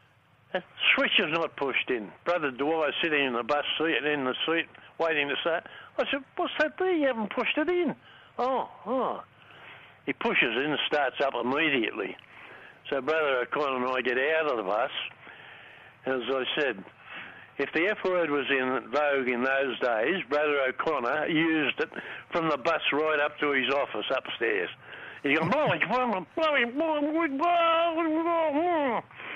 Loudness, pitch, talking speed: -27 LUFS, 160 Hz, 160 wpm